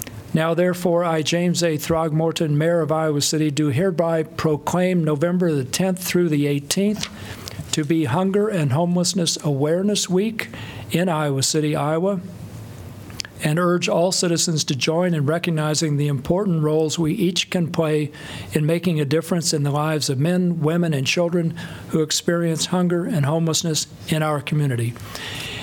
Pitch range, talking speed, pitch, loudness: 150-175 Hz, 150 wpm, 160 Hz, -21 LUFS